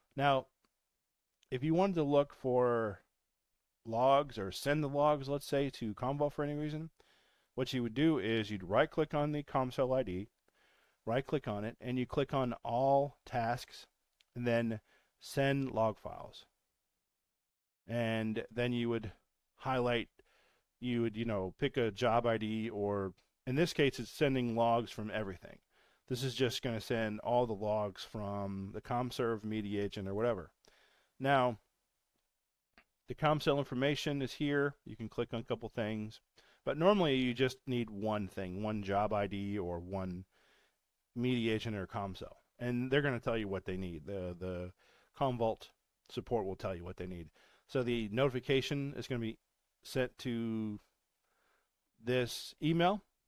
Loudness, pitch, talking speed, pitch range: -36 LUFS, 120 Hz, 160 wpm, 105-135 Hz